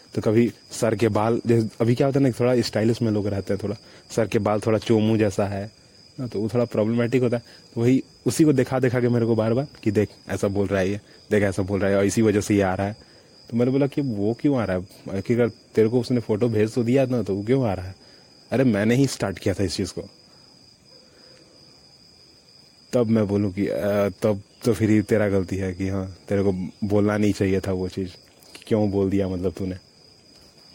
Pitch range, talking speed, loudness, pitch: 100-120 Hz, 240 wpm, -23 LUFS, 105 Hz